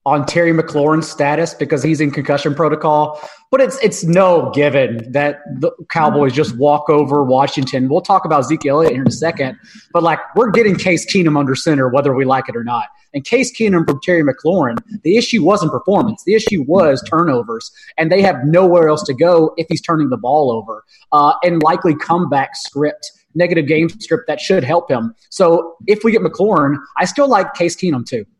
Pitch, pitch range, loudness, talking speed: 165 Hz, 145-190 Hz, -14 LUFS, 200 wpm